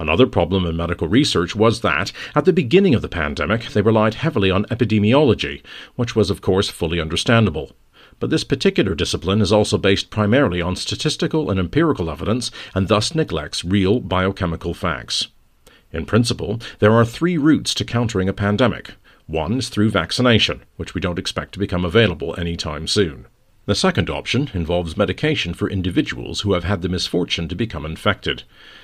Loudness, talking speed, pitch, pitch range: -19 LUFS, 170 wpm, 100 Hz, 85-115 Hz